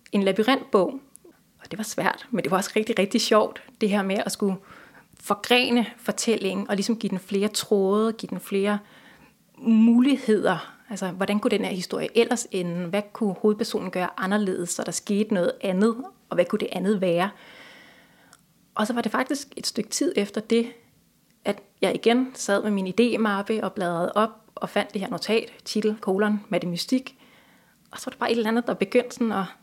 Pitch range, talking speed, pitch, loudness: 195-235 Hz, 190 wpm, 215 Hz, -24 LUFS